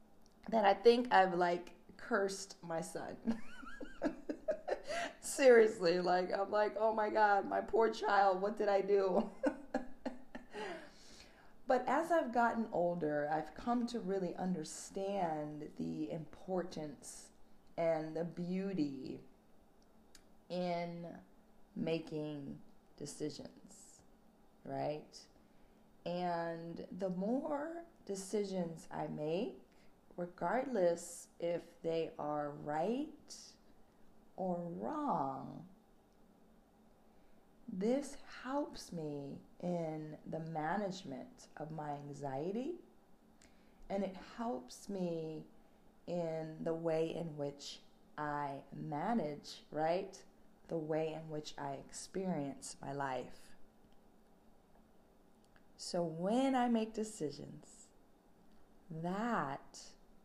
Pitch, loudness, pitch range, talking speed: 185 Hz, -38 LUFS, 160-220 Hz, 90 wpm